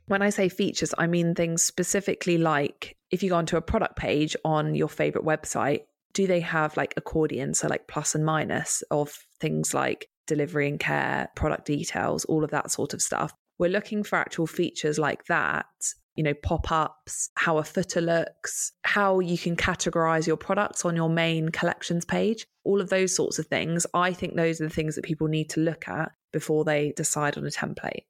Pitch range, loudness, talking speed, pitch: 155-180 Hz, -26 LUFS, 200 wpm, 165 Hz